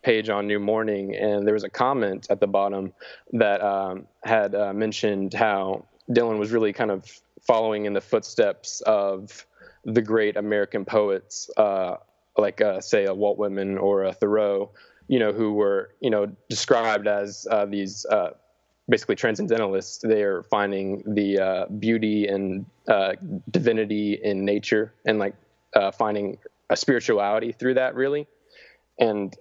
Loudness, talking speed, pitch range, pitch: -24 LUFS, 155 wpm, 100-110 Hz, 105 Hz